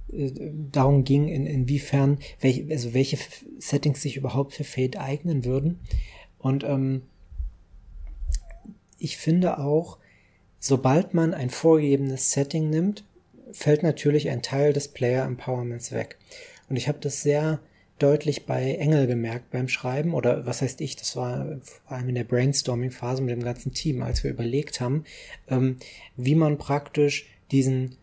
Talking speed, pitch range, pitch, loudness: 145 wpm, 125-150 Hz, 135 Hz, -25 LUFS